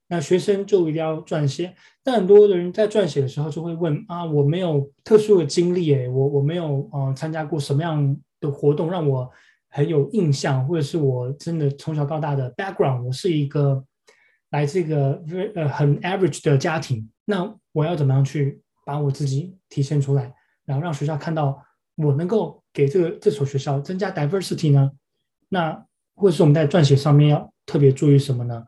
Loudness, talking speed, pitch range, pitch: -21 LUFS, 325 characters per minute, 140-175 Hz, 150 Hz